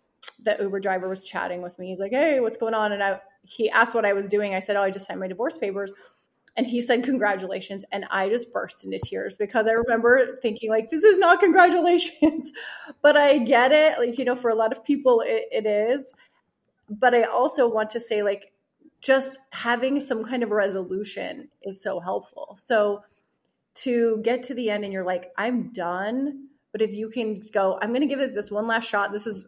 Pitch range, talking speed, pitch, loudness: 200-265 Hz, 215 wpm, 225 Hz, -23 LUFS